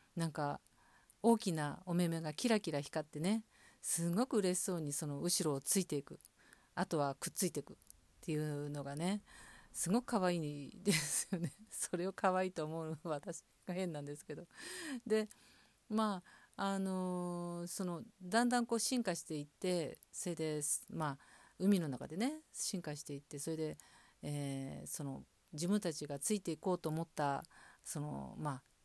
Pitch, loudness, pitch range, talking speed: 170 Hz, -39 LUFS, 150-195 Hz, 295 characters per minute